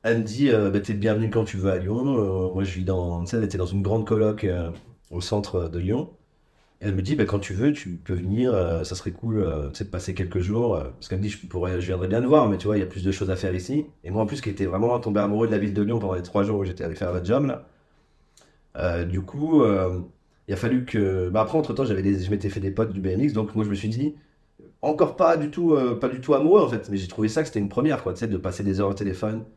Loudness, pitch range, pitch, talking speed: -24 LUFS, 95-115 Hz, 105 Hz, 300 wpm